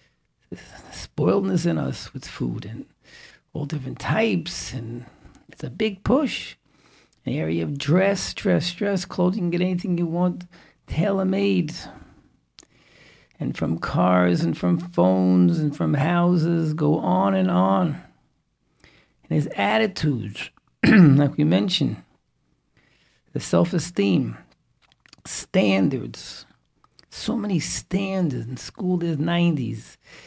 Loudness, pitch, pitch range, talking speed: -22 LUFS, 170 Hz, 125-185 Hz, 115 wpm